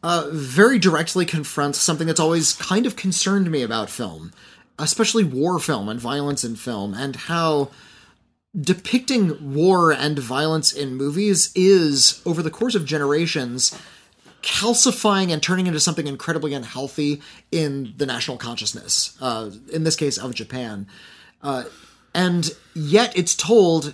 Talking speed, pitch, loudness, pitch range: 140 wpm, 155 Hz, -20 LUFS, 140-180 Hz